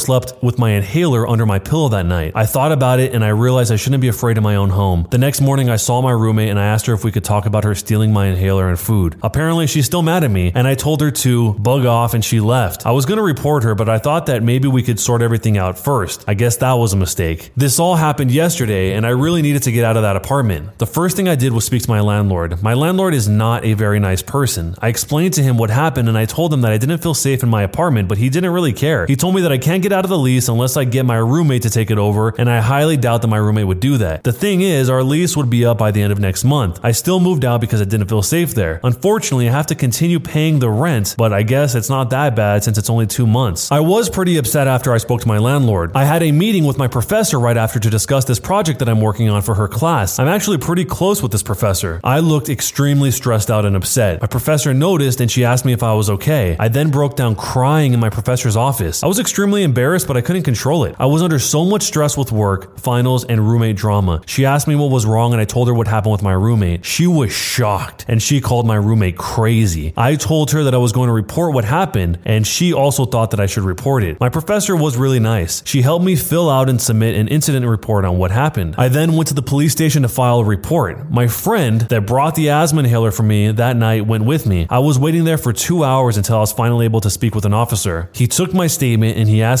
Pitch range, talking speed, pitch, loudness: 110-145 Hz, 275 wpm, 125 Hz, -15 LUFS